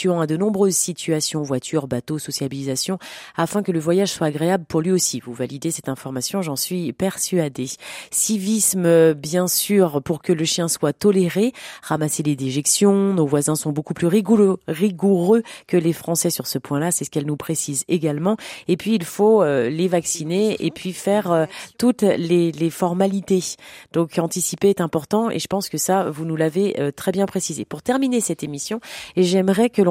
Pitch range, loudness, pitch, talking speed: 155-195 Hz, -20 LUFS, 175 Hz, 175 wpm